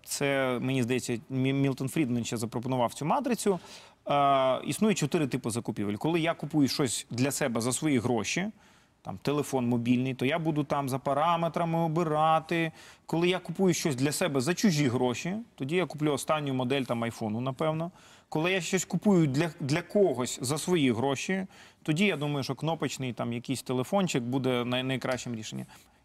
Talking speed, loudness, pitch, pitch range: 165 wpm, -29 LUFS, 145 Hz, 130-170 Hz